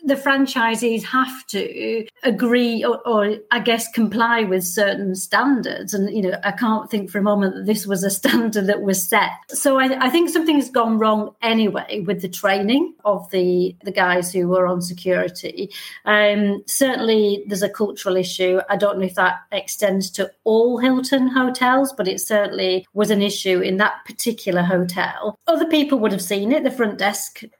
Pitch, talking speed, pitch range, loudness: 210 Hz, 185 wpm, 195-240 Hz, -19 LUFS